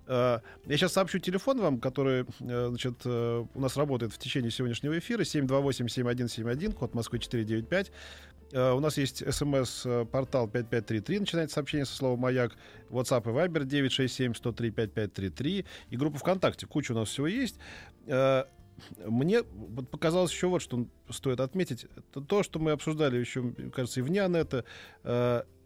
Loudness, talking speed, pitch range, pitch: -31 LUFS, 150 wpm, 120-150 Hz, 130 Hz